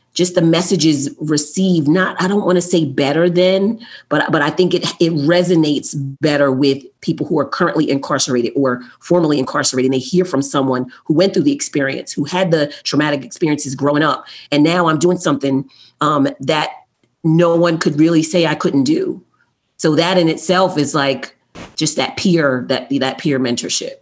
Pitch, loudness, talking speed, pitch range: 155 Hz, -16 LUFS, 185 wpm, 140-180 Hz